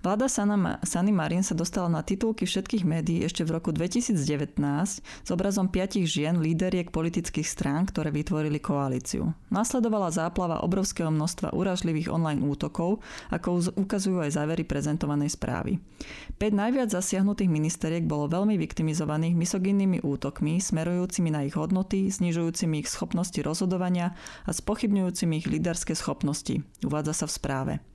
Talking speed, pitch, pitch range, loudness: 135 wpm, 175 Hz, 160-195 Hz, -28 LUFS